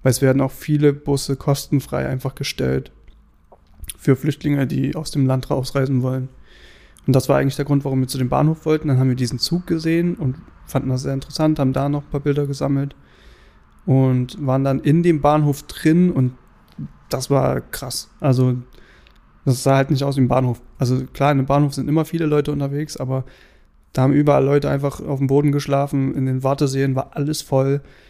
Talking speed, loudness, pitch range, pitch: 200 wpm, -19 LUFS, 130-145 Hz, 135 Hz